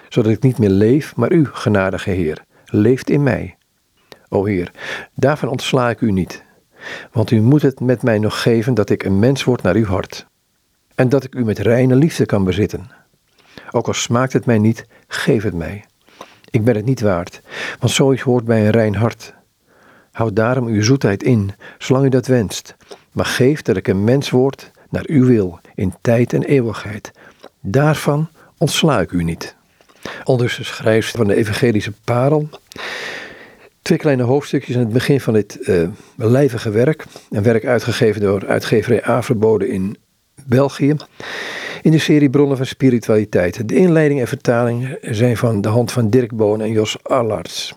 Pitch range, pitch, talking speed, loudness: 105-135 Hz, 120 Hz, 175 wpm, -16 LUFS